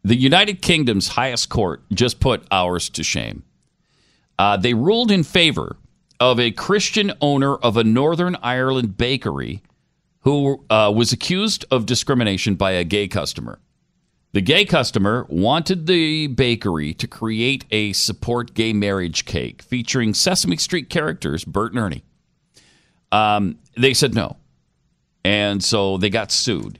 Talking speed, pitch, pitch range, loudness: 140 wpm, 120 Hz, 105-140 Hz, -18 LUFS